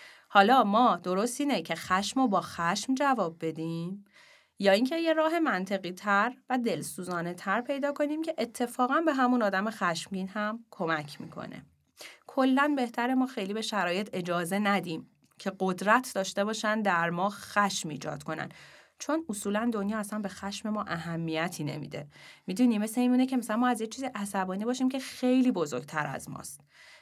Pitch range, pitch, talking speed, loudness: 185-250 Hz, 205 Hz, 160 wpm, -29 LUFS